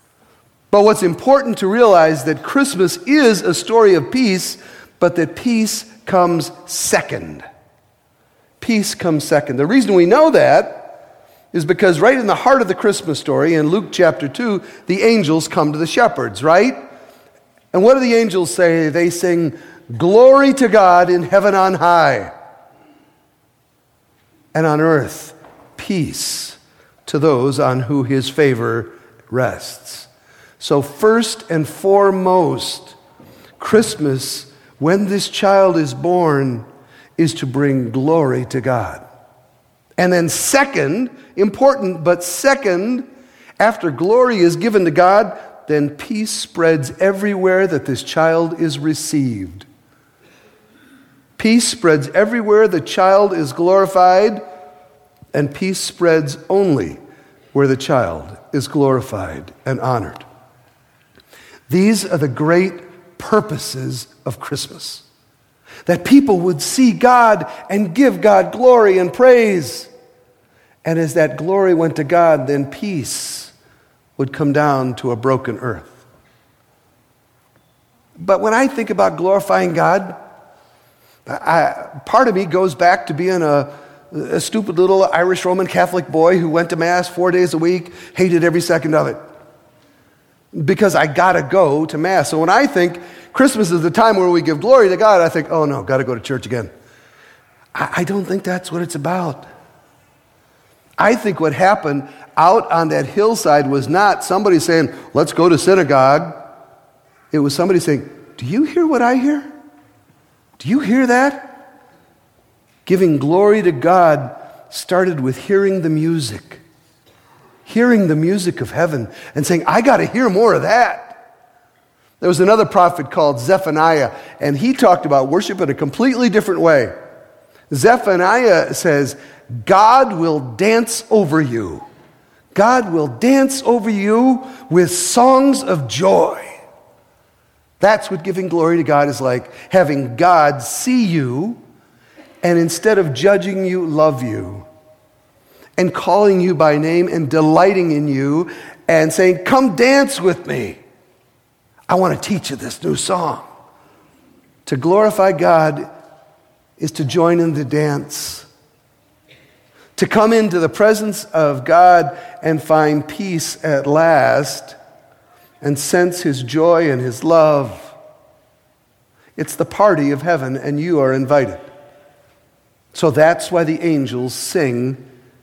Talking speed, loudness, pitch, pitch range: 140 wpm, -14 LUFS, 170 Hz, 145-195 Hz